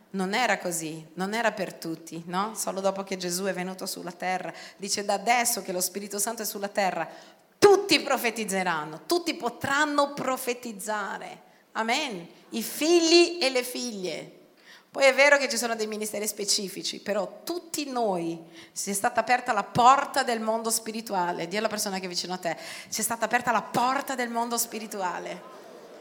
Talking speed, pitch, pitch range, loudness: 175 wpm, 220 Hz, 190-245 Hz, -26 LUFS